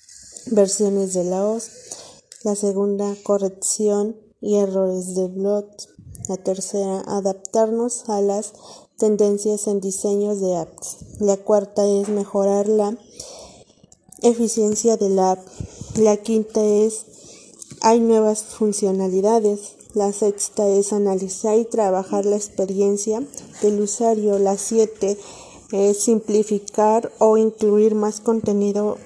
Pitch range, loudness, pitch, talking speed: 200-215 Hz, -20 LUFS, 205 Hz, 115 wpm